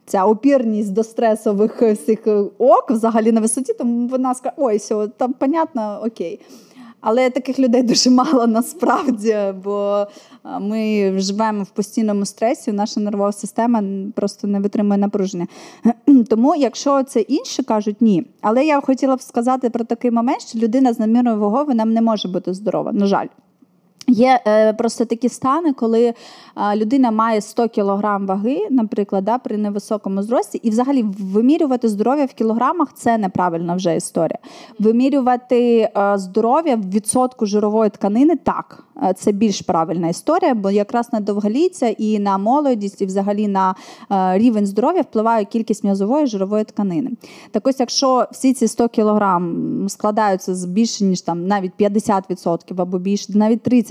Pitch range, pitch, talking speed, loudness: 205-250 Hz, 225 Hz, 145 wpm, -18 LUFS